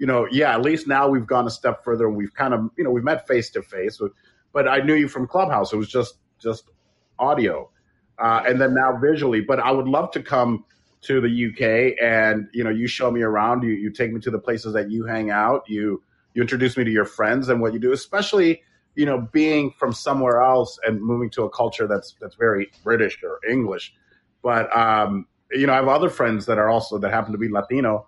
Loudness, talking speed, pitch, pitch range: -21 LUFS, 235 wpm, 120 Hz, 110-135 Hz